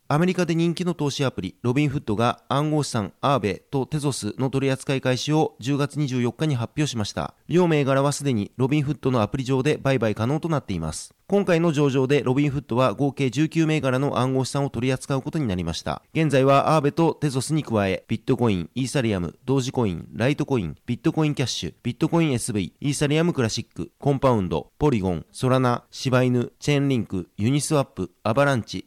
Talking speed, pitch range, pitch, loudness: 445 characters per minute, 120-150 Hz, 135 Hz, -23 LUFS